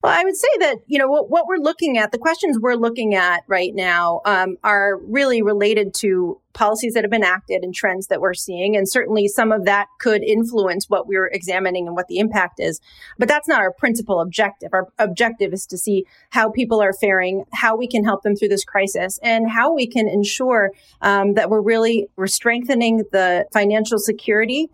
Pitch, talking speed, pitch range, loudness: 210 Hz, 210 wpm, 190-230 Hz, -18 LUFS